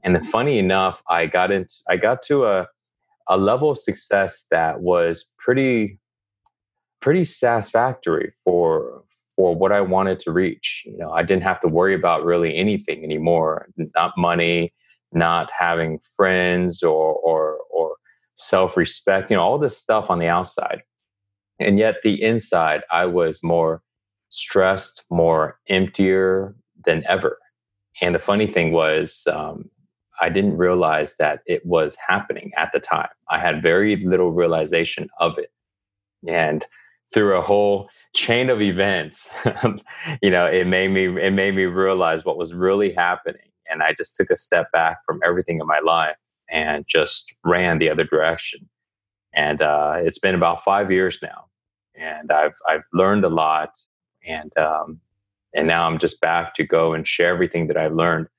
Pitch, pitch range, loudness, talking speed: 95 Hz, 85-100 Hz, -20 LUFS, 160 wpm